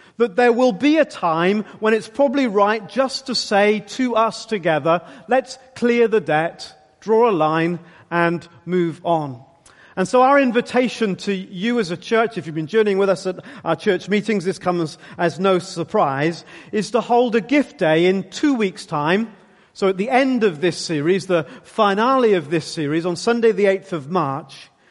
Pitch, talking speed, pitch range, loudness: 195 Hz, 190 wpm, 170-230 Hz, -19 LUFS